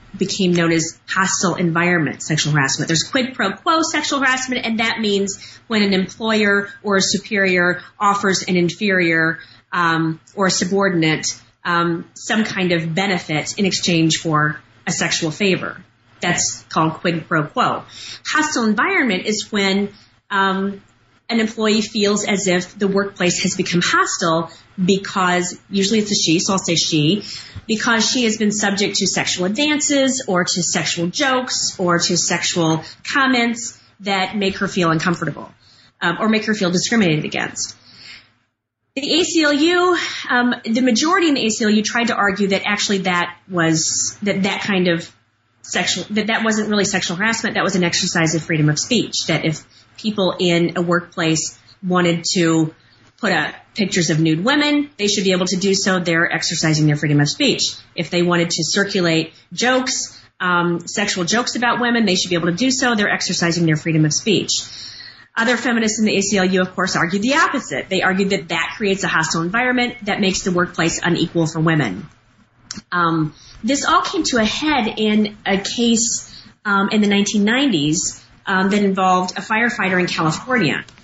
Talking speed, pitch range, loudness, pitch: 170 wpm, 170-215 Hz, -18 LUFS, 190 Hz